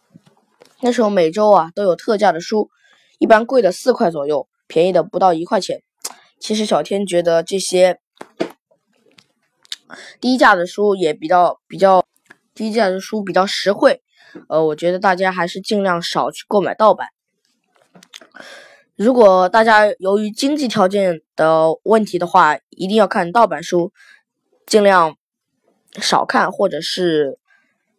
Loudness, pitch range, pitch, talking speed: -16 LUFS, 175-220 Hz, 195 Hz, 210 characters per minute